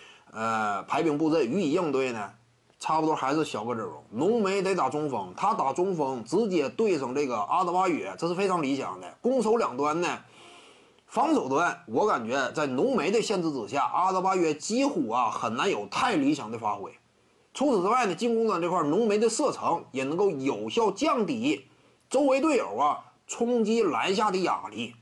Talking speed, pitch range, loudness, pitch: 275 characters per minute, 155-245 Hz, -27 LUFS, 190 Hz